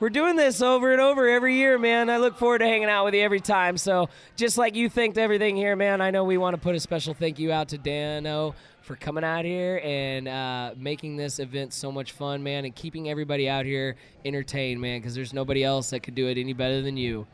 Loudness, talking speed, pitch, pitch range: -25 LUFS, 250 wpm, 155 Hz, 135-205 Hz